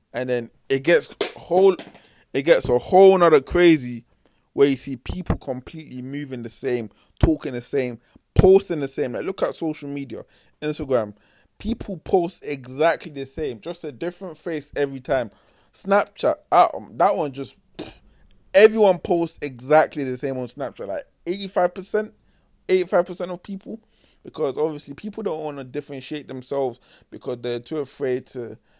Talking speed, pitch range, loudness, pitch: 155 wpm, 125-175 Hz, -22 LUFS, 145 Hz